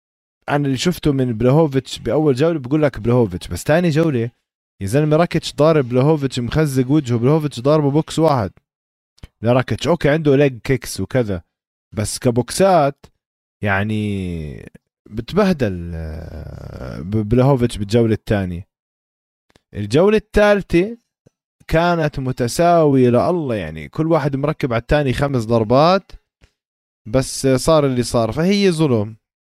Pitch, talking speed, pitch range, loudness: 130 Hz, 115 wpm, 105-155 Hz, -17 LUFS